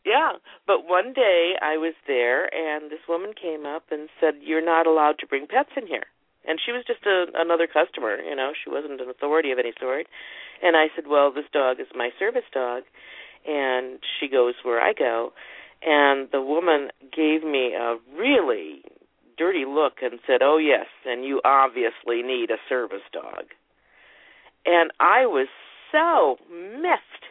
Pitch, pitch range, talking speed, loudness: 155 Hz, 135-180 Hz, 175 wpm, -23 LUFS